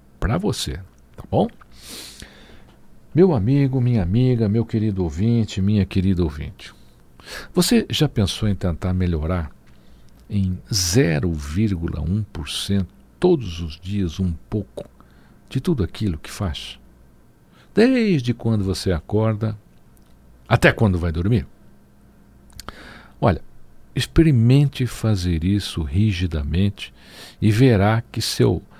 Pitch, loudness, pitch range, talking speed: 100 Hz, -21 LUFS, 80-115 Hz, 100 wpm